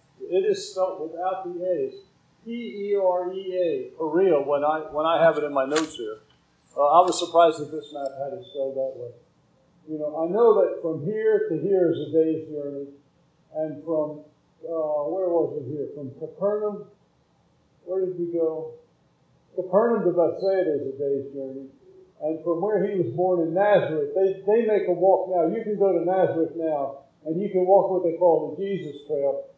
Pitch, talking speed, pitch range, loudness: 170 Hz, 190 wpm, 150-195 Hz, -24 LUFS